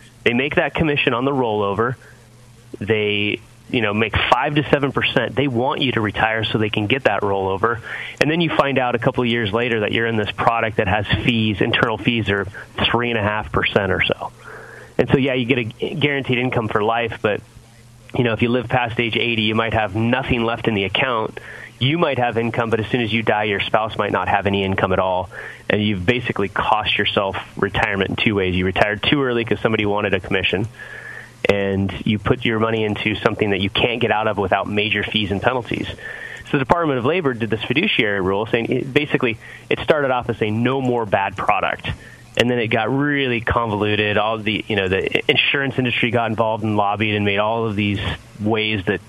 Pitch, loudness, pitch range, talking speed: 115 Hz, -19 LUFS, 105-120 Hz, 225 wpm